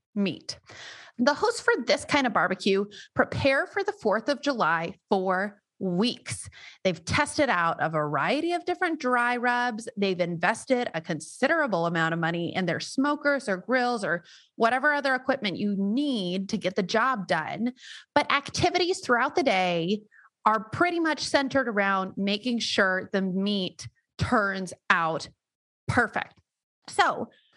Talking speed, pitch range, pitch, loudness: 145 wpm, 185-280 Hz, 220 Hz, -26 LUFS